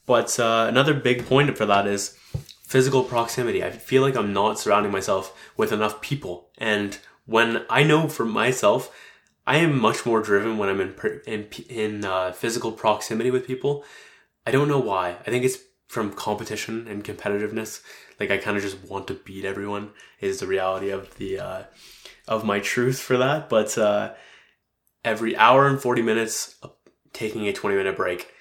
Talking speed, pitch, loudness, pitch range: 180 wpm, 110 Hz, -23 LUFS, 100-125 Hz